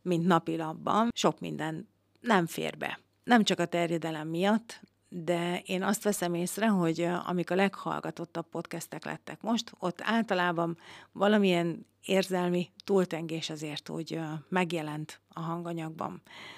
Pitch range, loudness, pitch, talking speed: 165-190 Hz, -31 LUFS, 175 Hz, 125 wpm